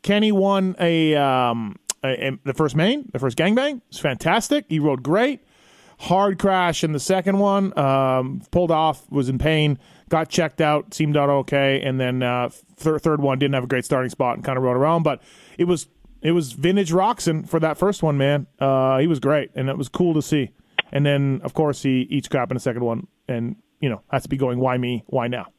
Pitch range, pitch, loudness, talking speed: 135-170 Hz, 150 Hz, -21 LUFS, 225 wpm